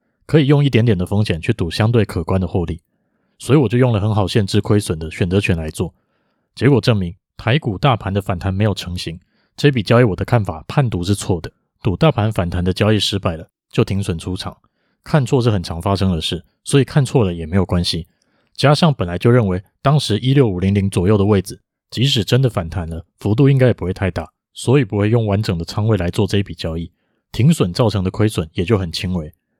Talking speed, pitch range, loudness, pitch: 330 characters per minute, 90-120 Hz, -17 LUFS, 105 Hz